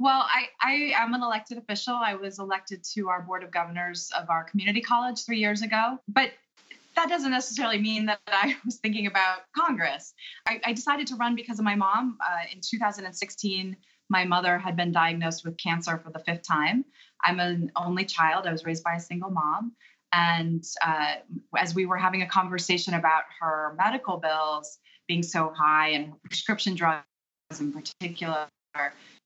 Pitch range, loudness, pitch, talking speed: 165-225 Hz, -27 LUFS, 185 Hz, 180 wpm